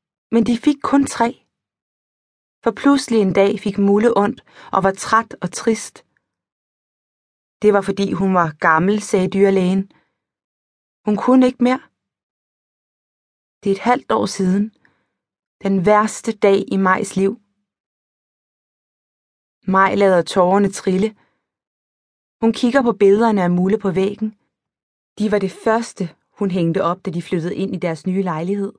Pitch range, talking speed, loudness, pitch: 190-225 Hz, 140 wpm, -17 LUFS, 200 Hz